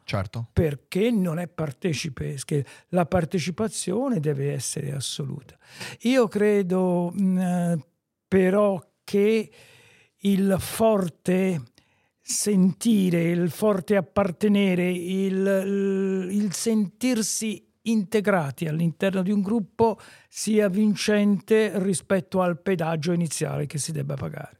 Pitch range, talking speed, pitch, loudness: 170-205 Hz, 90 wpm, 190 Hz, -24 LUFS